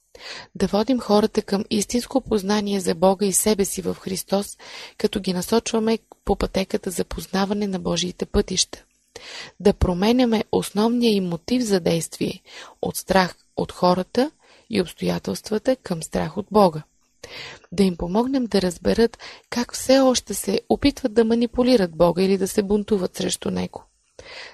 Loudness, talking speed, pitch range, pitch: -22 LUFS, 145 wpm, 190-240 Hz, 210 Hz